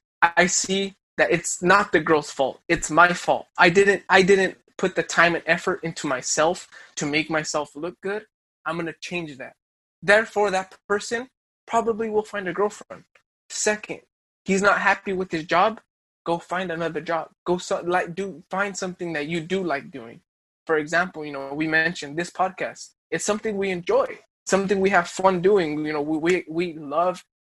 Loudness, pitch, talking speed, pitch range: -23 LUFS, 180 Hz, 185 wpm, 165-195 Hz